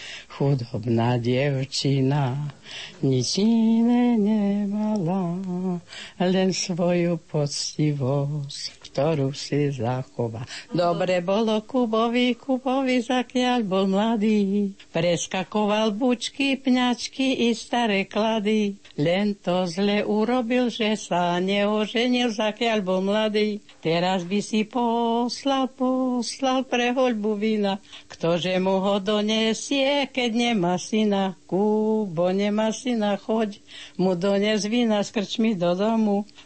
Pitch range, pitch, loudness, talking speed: 175-230 Hz, 205 Hz, -23 LUFS, 95 wpm